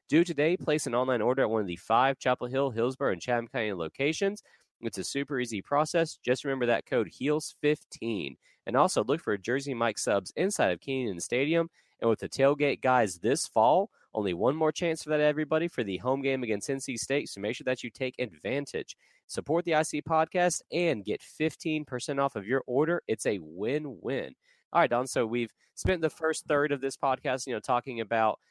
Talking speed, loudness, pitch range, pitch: 205 wpm, -29 LUFS, 120-155 Hz, 135 Hz